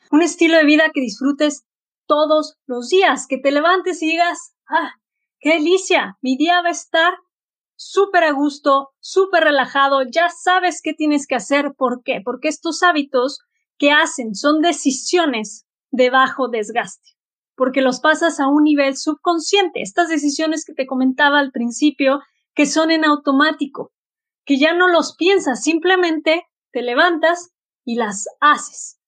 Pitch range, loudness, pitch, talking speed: 275-340 Hz, -17 LUFS, 305 Hz, 155 wpm